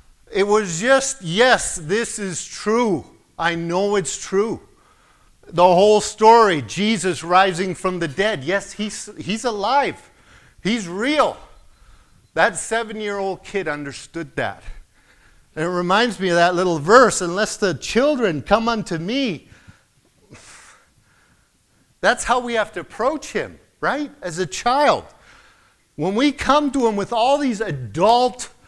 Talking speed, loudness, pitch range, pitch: 140 wpm, -19 LUFS, 175-230 Hz, 200 Hz